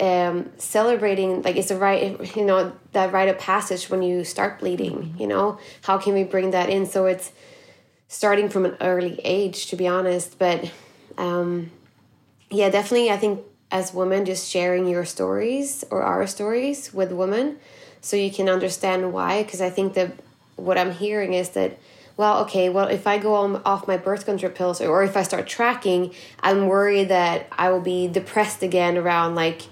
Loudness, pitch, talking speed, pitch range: -22 LUFS, 190 Hz, 190 wpm, 180-200 Hz